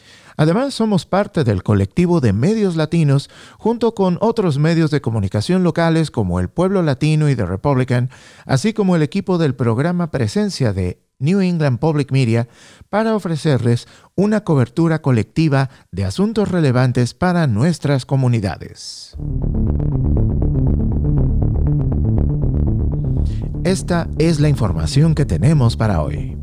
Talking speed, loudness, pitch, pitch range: 120 wpm, -17 LUFS, 145 Hz, 115-175 Hz